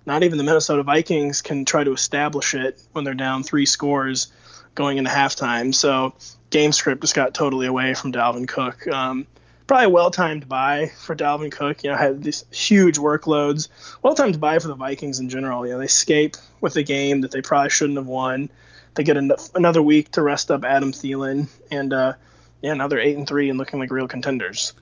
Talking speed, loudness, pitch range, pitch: 205 wpm, -20 LUFS, 130-150 Hz, 140 Hz